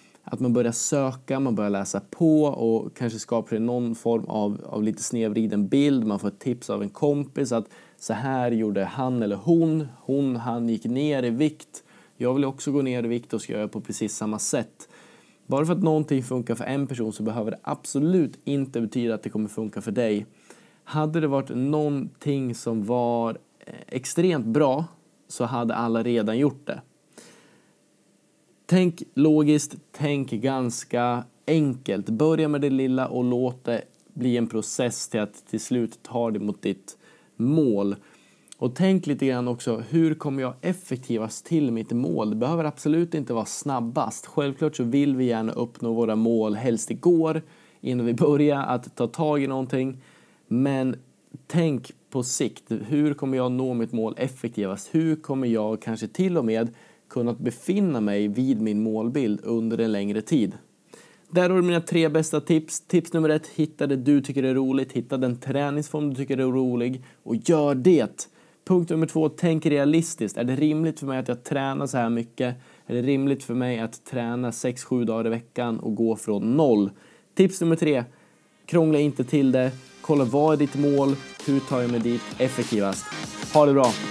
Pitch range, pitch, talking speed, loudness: 115-150 Hz, 130 Hz, 180 wpm, -25 LUFS